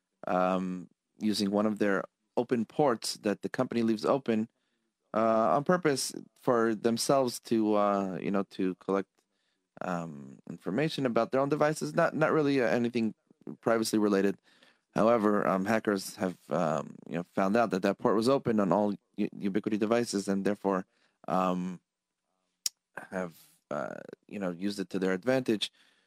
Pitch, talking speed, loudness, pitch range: 105 Hz, 150 wpm, -30 LUFS, 95-120 Hz